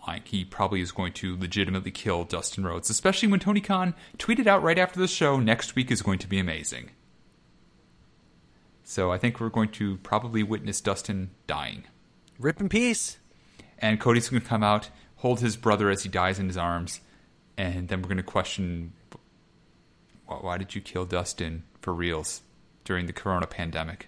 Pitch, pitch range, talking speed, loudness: 95 Hz, 90-115 Hz, 175 wpm, -27 LUFS